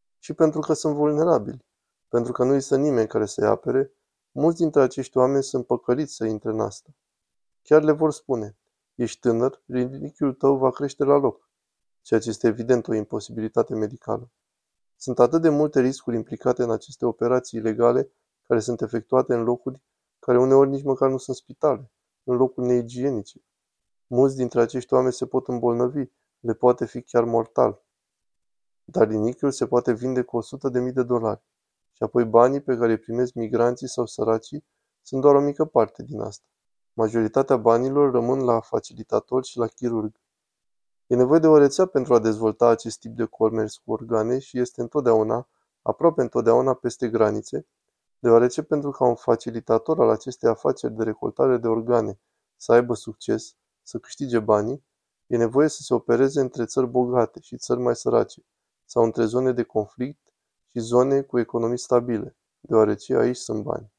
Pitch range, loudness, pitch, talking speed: 115-135 Hz, -22 LUFS, 125 Hz, 170 wpm